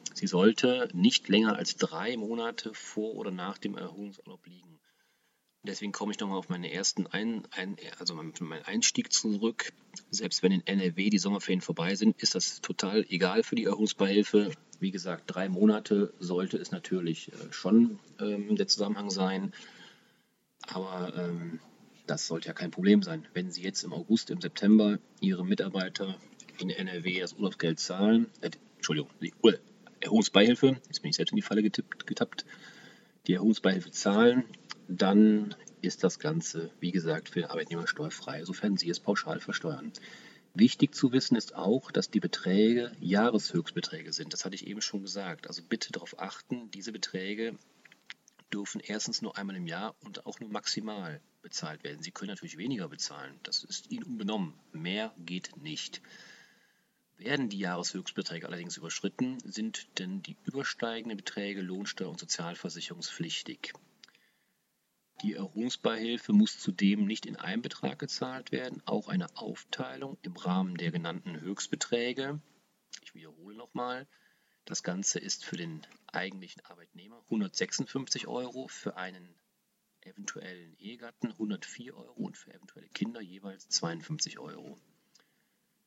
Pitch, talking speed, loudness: 110 Hz, 145 wpm, -31 LUFS